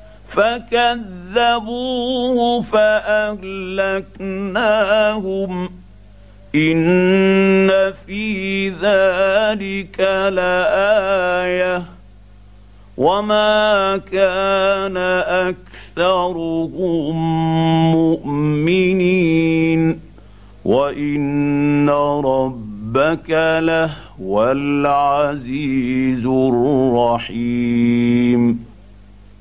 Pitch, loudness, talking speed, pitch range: 165 Hz, -17 LUFS, 30 wpm, 130-195 Hz